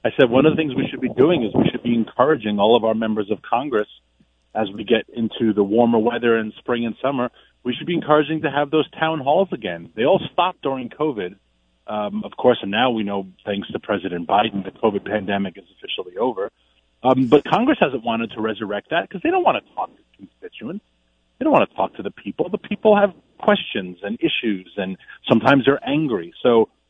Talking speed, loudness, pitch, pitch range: 220 wpm, -20 LUFS, 120 Hz, 105-155 Hz